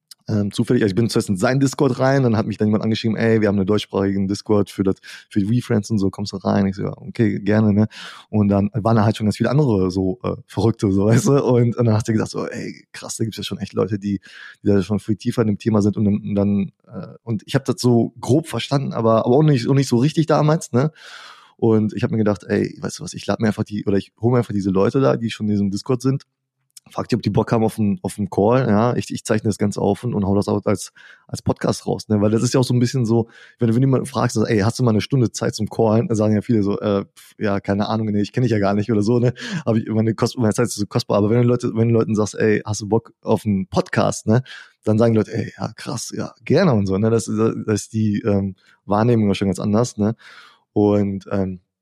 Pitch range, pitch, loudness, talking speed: 100-120 Hz, 110 Hz, -19 LUFS, 285 wpm